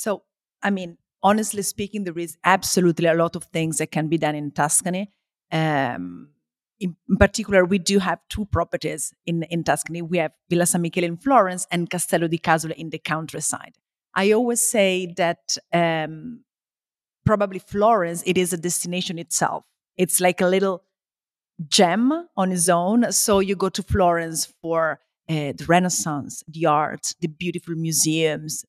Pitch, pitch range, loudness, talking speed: 175 Hz, 160-190 Hz, -22 LUFS, 160 wpm